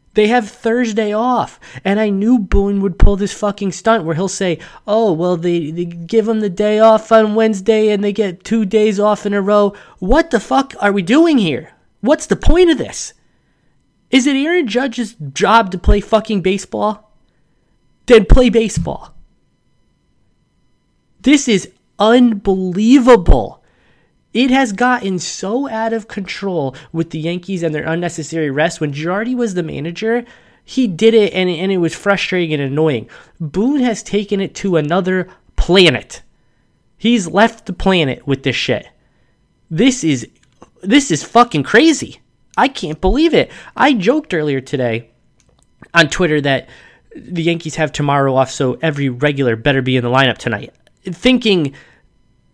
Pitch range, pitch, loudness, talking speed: 165-225 Hz, 200 Hz, -15 LUFS, 160 wpm